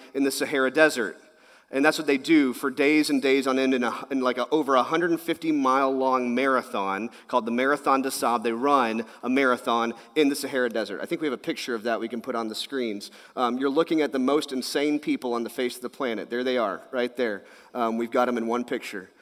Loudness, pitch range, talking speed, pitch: -25 LUFS, 120-140 Hz, 255 wpm, 130 Hz